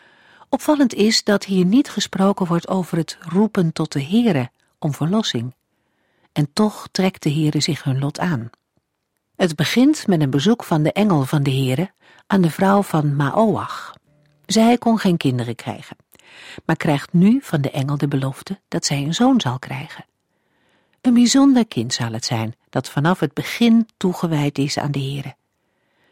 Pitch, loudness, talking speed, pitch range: 165 Hz, -19 LUFS, 170 wpm, 145-200 Hz